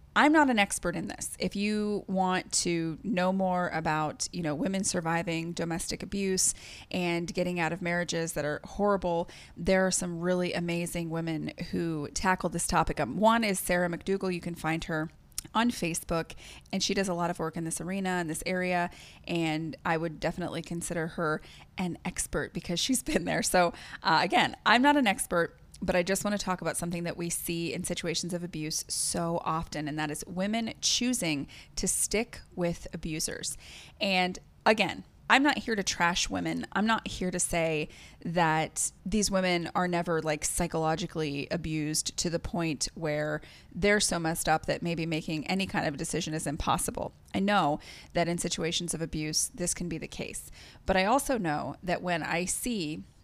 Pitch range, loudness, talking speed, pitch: 160-190 Hz, -30 LUFS, 185 wpm, 175 Hz